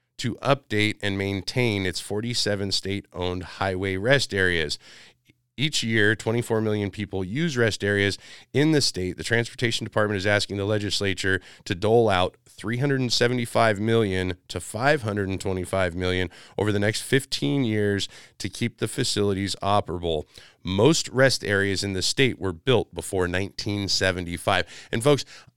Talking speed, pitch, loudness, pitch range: 135 wpm, 105 Hz, -24 LUFS, 95-120 Hz